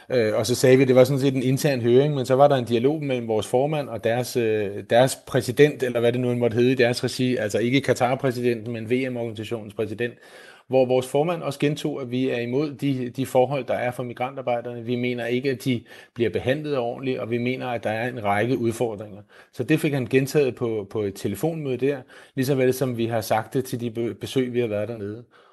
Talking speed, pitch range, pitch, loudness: 225 wpm, 120-135 Hz, 125 Hz, -23 LUFS